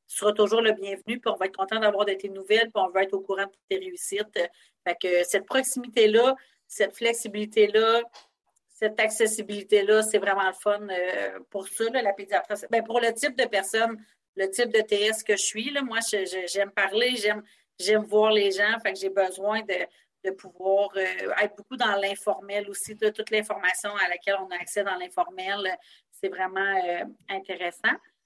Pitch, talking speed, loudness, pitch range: 210 Hz, 190 wpm, -26 LUFS, 195-225 Hz